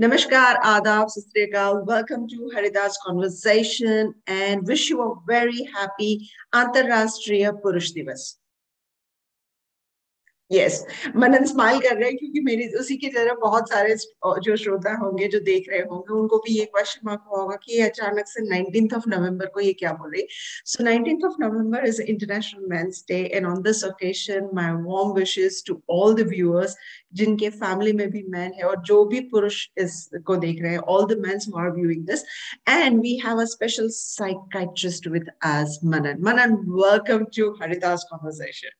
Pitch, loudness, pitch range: 210 Hz, -22 LUFS, 190-225 Hz